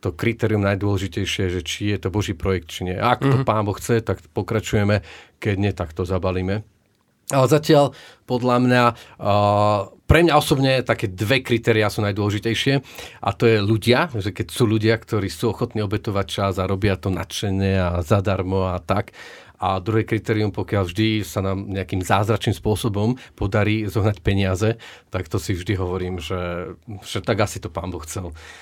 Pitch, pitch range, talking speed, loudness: 105 Hz, 95-115 Hz, 175 wpm, -21 LUFS